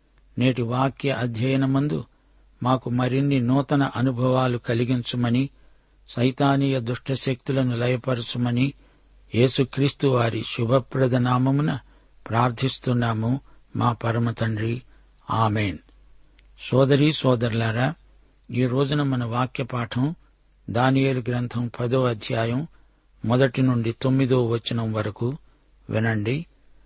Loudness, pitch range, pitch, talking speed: -23 LUFS, 120-135 Hz, 125 Hz, 85 wpm